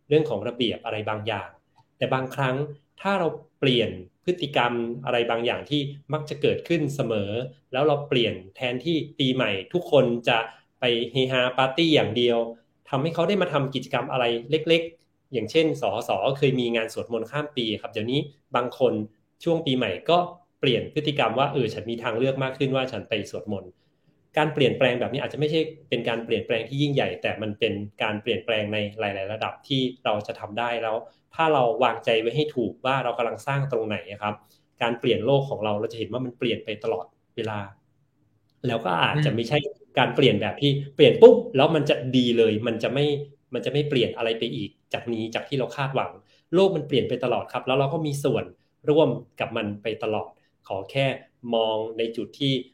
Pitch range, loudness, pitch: 115-145 Hz, -25 LUFS, 125 Hz